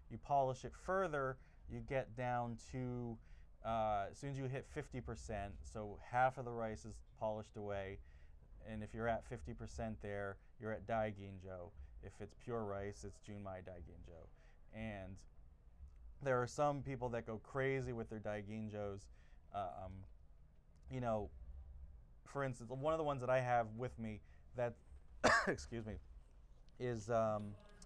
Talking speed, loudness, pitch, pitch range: 150 wpm, -43 LUFS, 110 Hz, 90-120 Hz